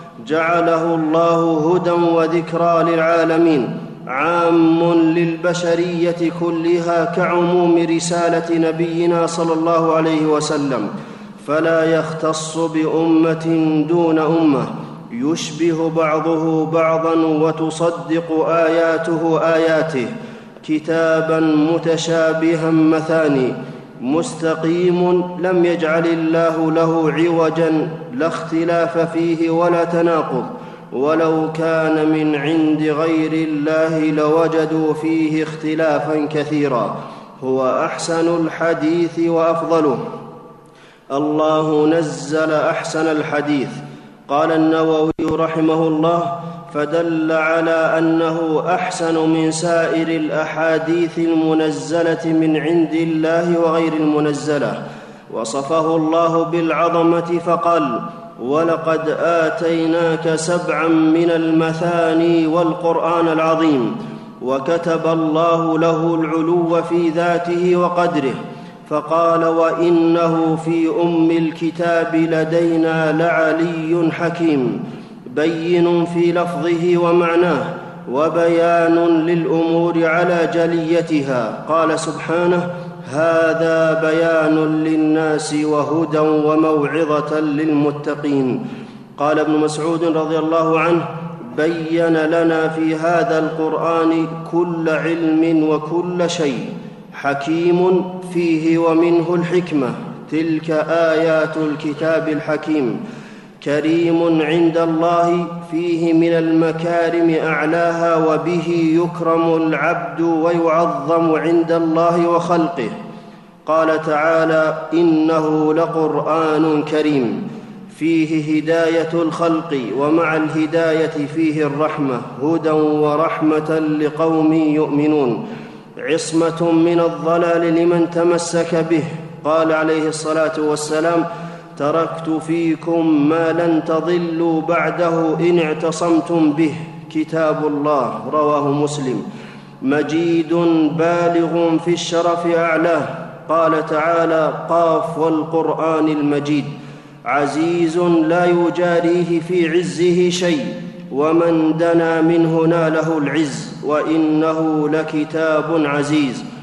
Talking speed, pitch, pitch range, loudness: 85 wpm, 165 Hz, 155-170 Hz, -17 LUFS